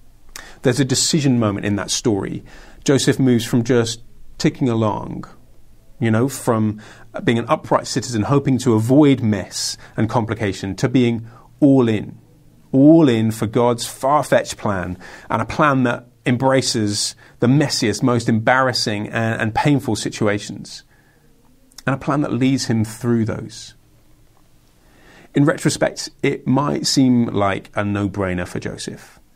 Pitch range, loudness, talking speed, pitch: 110-130 Hz, -18 LUFS, 140 wpm, 120 Hz